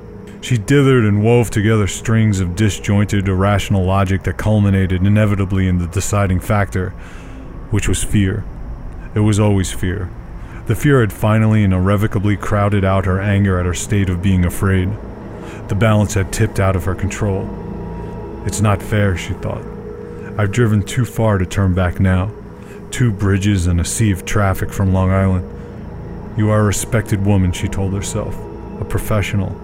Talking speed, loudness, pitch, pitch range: 165 wpm, -16 LUFS, 100 Hz, 95-105 Hz